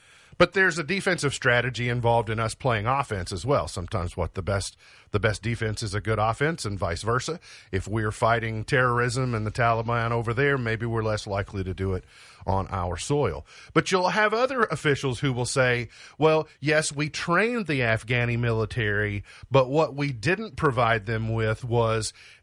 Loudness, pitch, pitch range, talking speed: -25 LUFS, 120 Hz, 110-140 Hz, 185 wpm